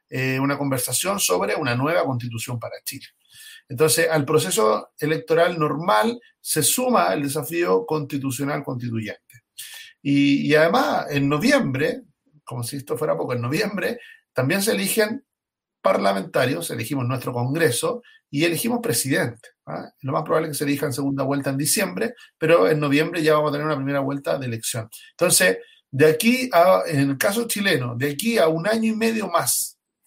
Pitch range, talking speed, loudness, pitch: 140-215 Hz, 165 wpm, -21 LUFS, 155 Hz